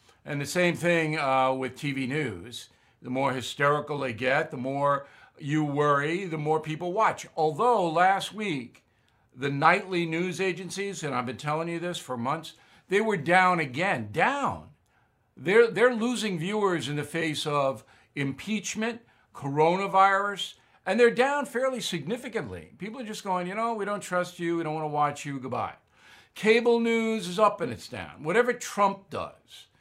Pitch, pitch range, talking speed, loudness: 170 Hz, 145-205 Hz, 165 wpm, -27 LUFS